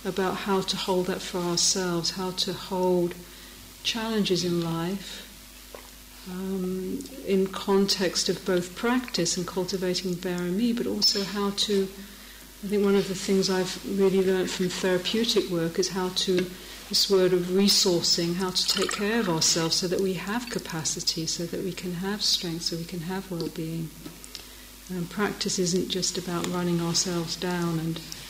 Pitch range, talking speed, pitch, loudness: 175-195 Hz, 165 wpm, 185 Hz, -26 LUFS